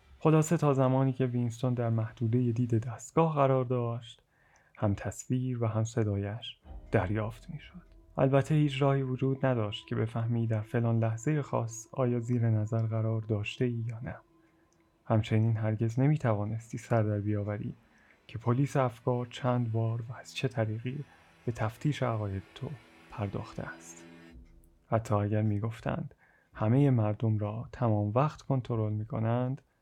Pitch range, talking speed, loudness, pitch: 110-130 Hz, 145 wpm, -31 LUFS, 115 Hz